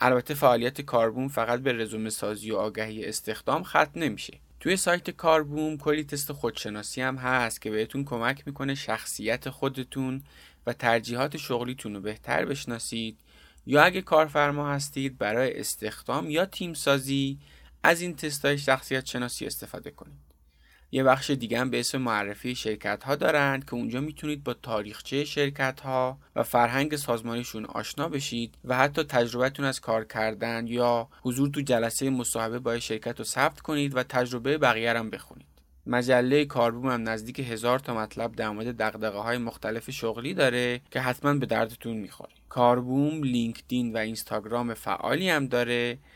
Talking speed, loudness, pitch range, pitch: 150 wpm, -28 LUFS, 115-140 Hz, 125 Hz